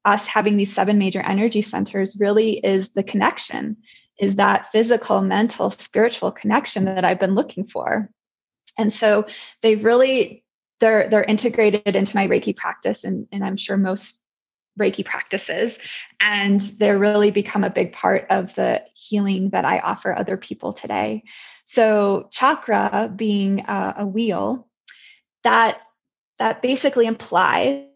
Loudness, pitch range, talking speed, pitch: -20 LUFS, 200-225 Hz, 140 wpm, 210 Hz